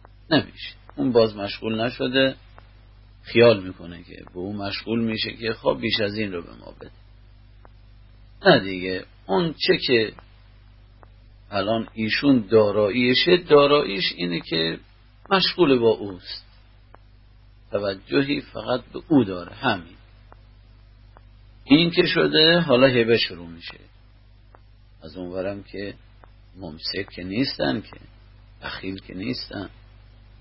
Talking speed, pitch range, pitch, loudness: 115 wpm, 100-110 Hz, 105 Hz, -21 LUFS